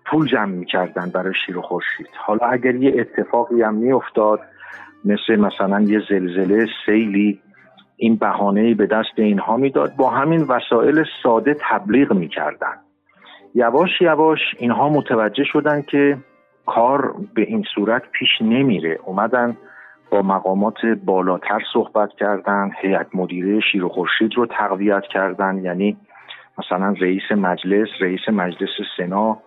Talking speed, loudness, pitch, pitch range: 125 wpm, -18 LUFS, 105 Hz, 95-120 Hz